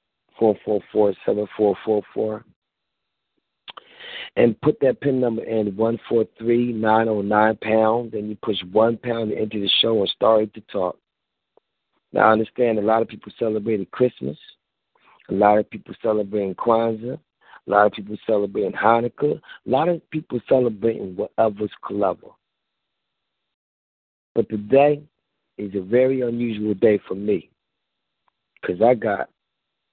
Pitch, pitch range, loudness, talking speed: 110 Hz, 105-115 Hz, -21 LUFS, 145 wpm